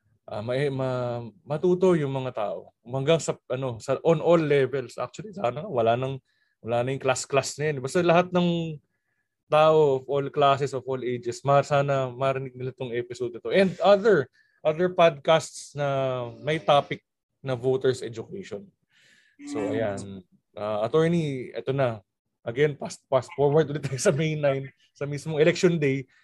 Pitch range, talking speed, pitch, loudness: 130-155 Hz, 160 wpm, 140 Hz, -25 LUFS